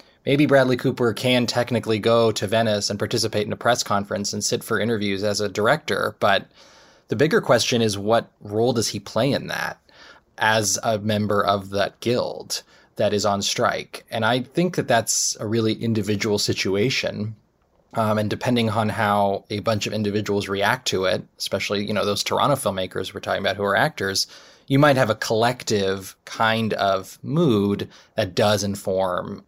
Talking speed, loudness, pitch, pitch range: 175 wpm, -22 LUFS, 110 Hz, 100-115 Hz